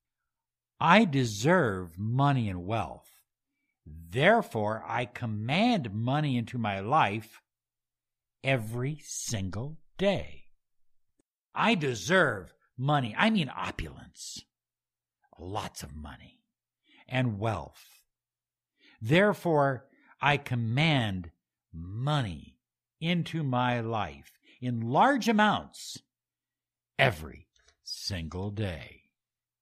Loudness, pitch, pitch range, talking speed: -28 LUFS, 120 Hz, 100-150 Hz, 80 wpm